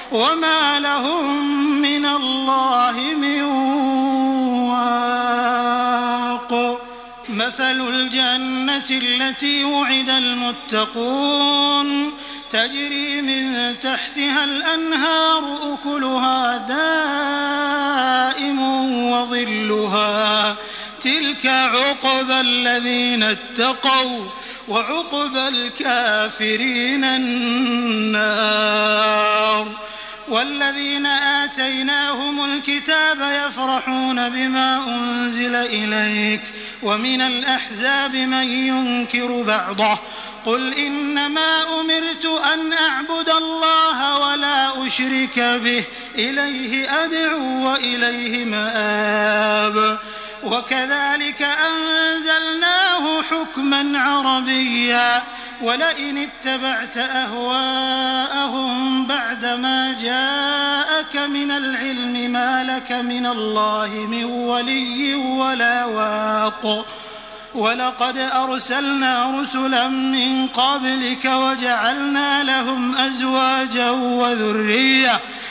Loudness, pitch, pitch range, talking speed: -18 LUFS, 260 Hz, 240-280 Hz, 65 wpm